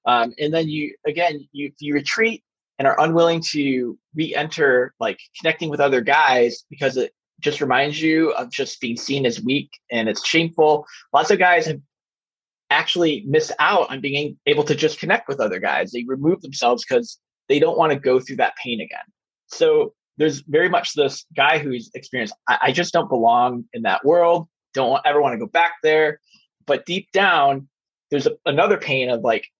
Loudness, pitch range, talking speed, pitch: -19 LUFS, 140-170 Hz, 190 wpm, 155 Hz